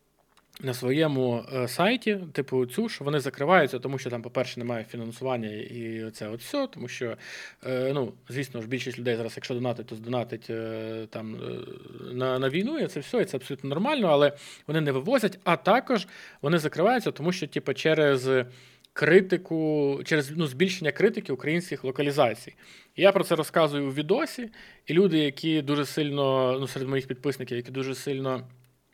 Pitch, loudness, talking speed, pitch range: 140 Hz, -27 LUFS, 160 wpm, 125-165 Hz